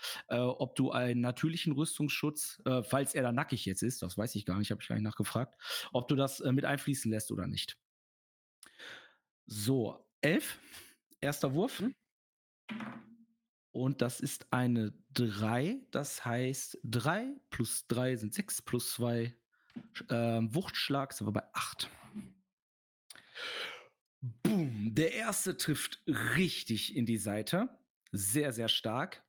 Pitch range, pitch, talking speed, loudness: 115-155 Hz, 130 Hz, 135 wpm, -35 LUFS